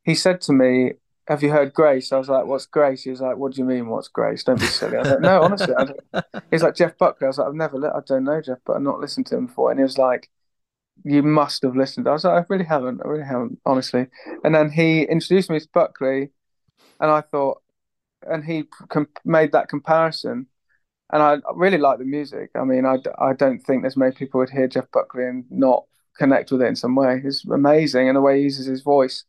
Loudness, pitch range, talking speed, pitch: -20 LUFS, 130-155 Hz, 250 wpm, 140 Hz